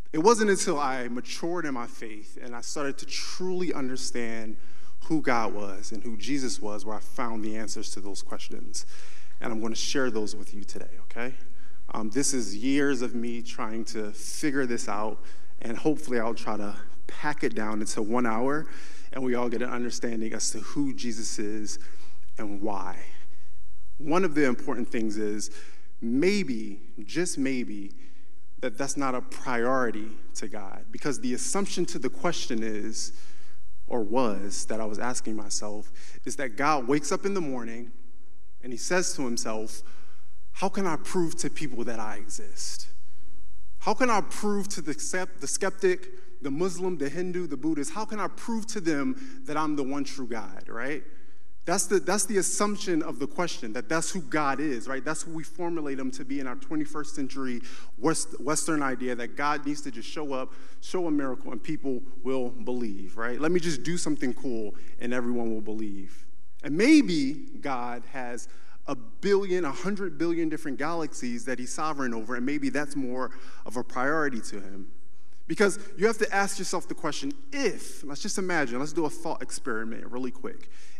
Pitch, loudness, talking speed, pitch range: 125 Hz, -30 LUFS, 185 wpm, 110-165 Hz